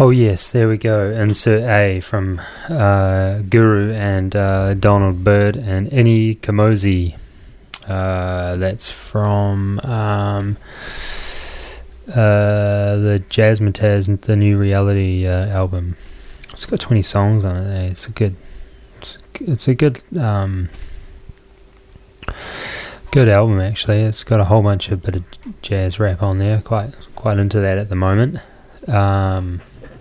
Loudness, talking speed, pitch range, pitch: -16 LUFS, 135 wpm, 95-110 Hz, 100 Hz